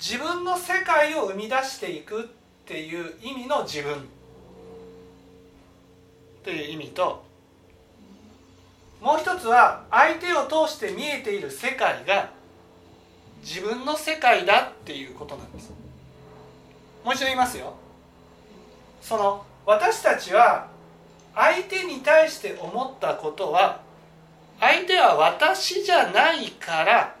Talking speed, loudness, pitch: 225 characters per minute, -22 LUFS, 260 Hz